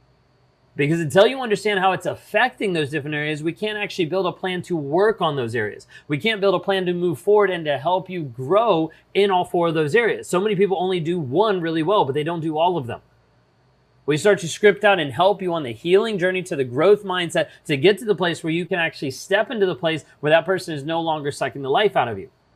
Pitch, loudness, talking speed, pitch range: 175 Hz, -21 LUFS, 255 wpm, 160-200 Hz